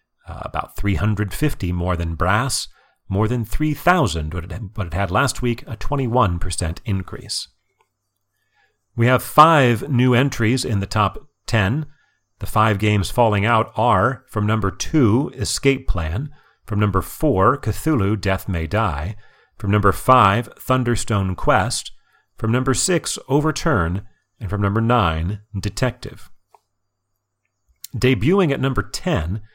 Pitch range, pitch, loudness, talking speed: 100-125 Hz, 105 Hz, -20 LUFS, 125 wpm